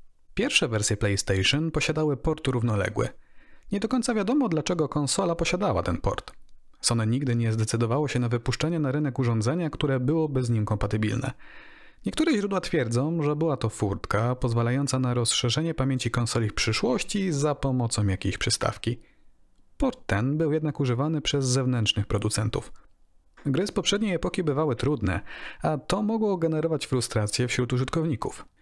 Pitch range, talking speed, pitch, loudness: 115-160 Hz, 145 wpm, 130 Hz, -26 LUFS